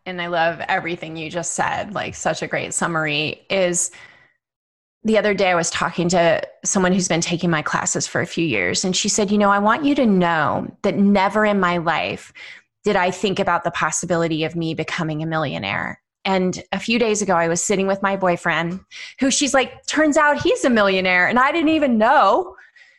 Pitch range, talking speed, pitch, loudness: 170-215 Hz, 210 wpm, 190 Hz, -19 LUFS